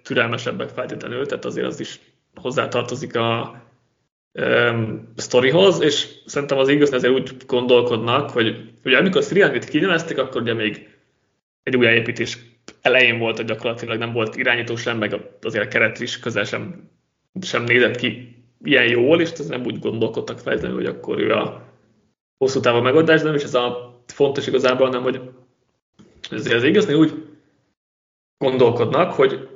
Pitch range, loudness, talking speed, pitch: 115-135 Hz, -19 LUFS, 155 wpm, 125 Hz